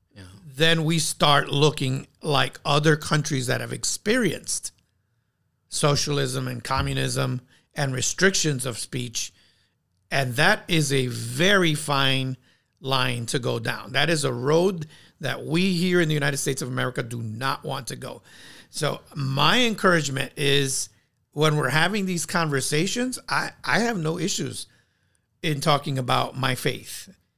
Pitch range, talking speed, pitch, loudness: 125-155 Hz, 140 wpm, 140 Hz, -23 LUFS